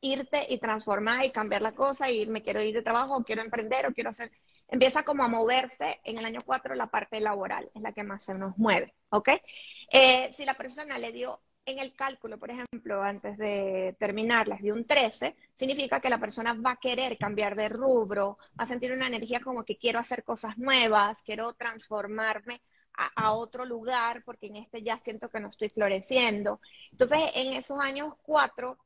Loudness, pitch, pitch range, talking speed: -29 LUFS, 235 Hz, 215-260 Hz, 200 wpm